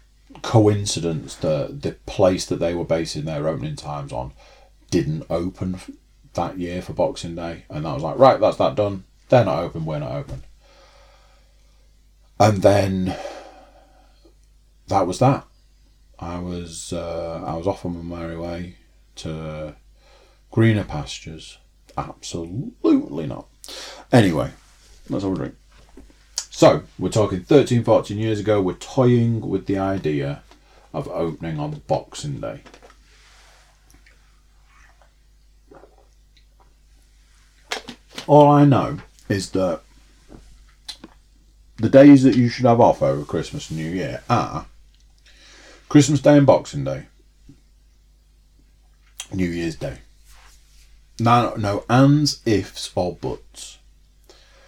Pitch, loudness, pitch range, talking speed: 90 Hz, -20 LUFS, 80-115 Hz, 115 wpm